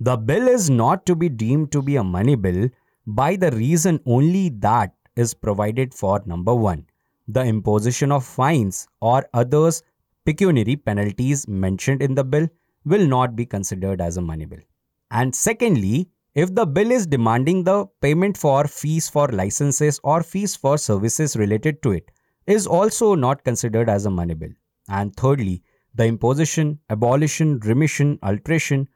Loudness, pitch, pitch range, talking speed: -20 LUFS, 130 Hz, 110-155 Hz, 160 wpm